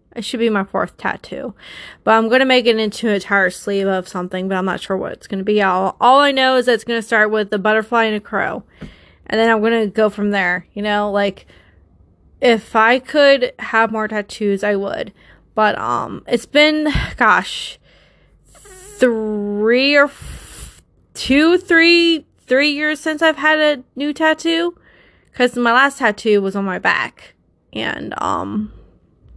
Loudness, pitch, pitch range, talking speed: -16 LUFS, 225 Hz, 200-265 Hz, 185 wpm